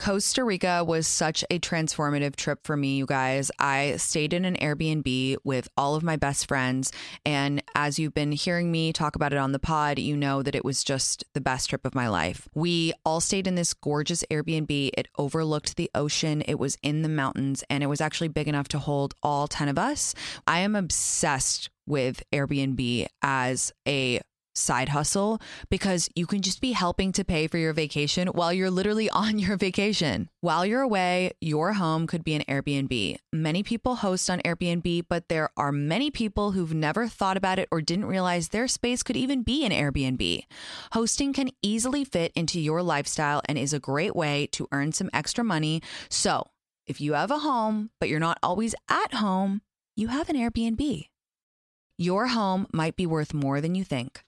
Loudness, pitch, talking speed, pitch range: -26 LUFS, 160 Hz, 195 wpm, 145-190 Hz